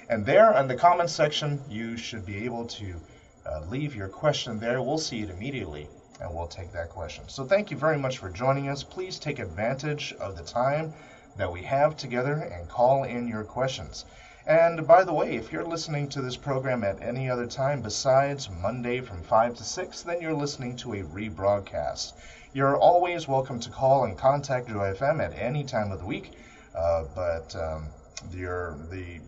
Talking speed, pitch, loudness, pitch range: 195 wpm, 120 Hz, -27 LUFS, 95-140 Hz